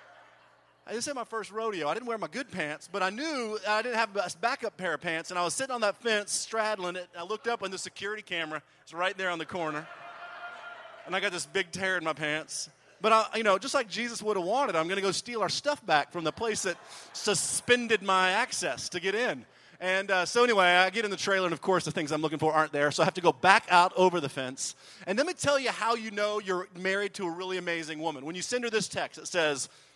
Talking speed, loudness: 270 wpm, -29 LUFS